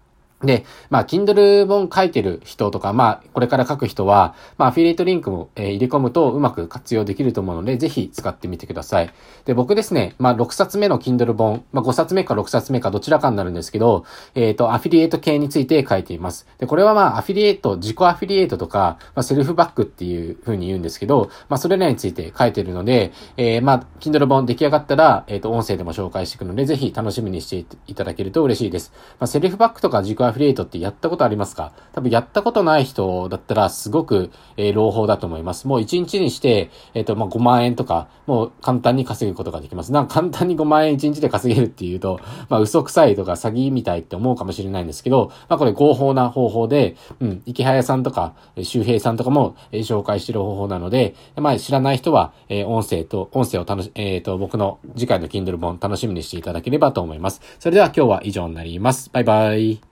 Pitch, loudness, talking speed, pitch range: 120 Hz, -19 LUFS, 480 characters per minute, 100-140 Hz